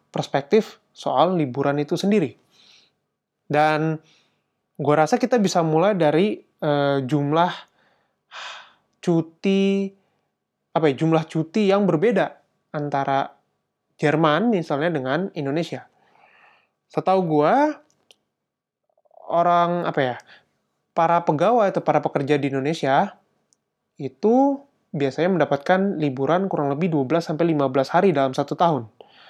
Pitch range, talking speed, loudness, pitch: 145-185 Hz, 105 wpm, -21 LUFS, 160 Hz